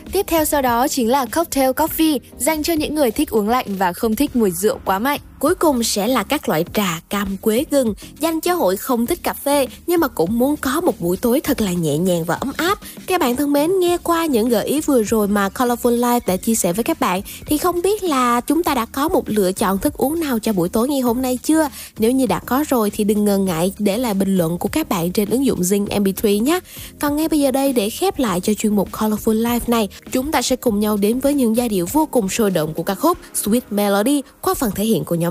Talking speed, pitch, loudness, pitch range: 265 wpm, 245 Hz, -18 LUFS, 210-290 Hz